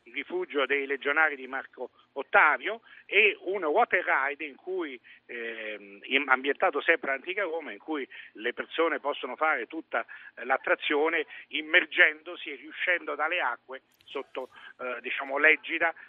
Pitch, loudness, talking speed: 160 Hz, -27 LUFS, 130 wpm